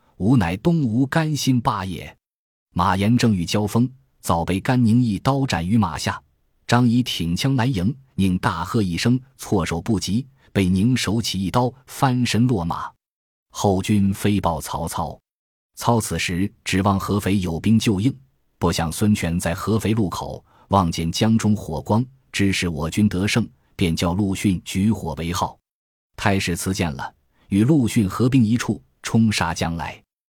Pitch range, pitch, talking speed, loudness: 90-120 Hz, 105 Hz, 220 characters per minute, -21 LUFS